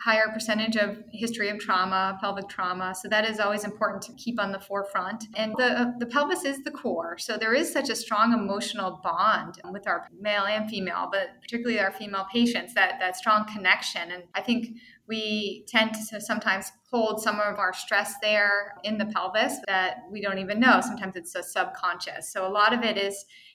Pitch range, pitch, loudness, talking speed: 195-225 Hz, 210 Hz, -26 LUFS, 200 wpm